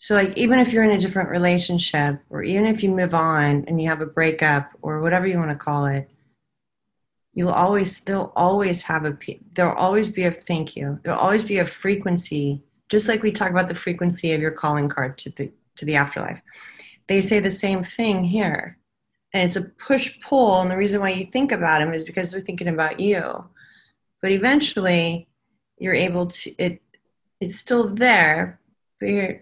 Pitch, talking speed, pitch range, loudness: 180 Hz, 195 wpm, 160-200 Hz, -21 LUFS